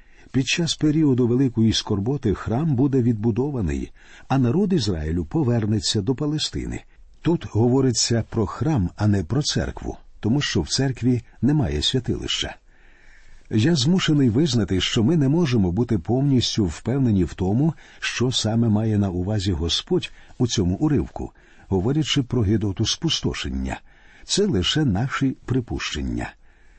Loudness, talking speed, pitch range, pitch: -22 LUFS, 130 wpm, 100-135 Hz, 120 Hz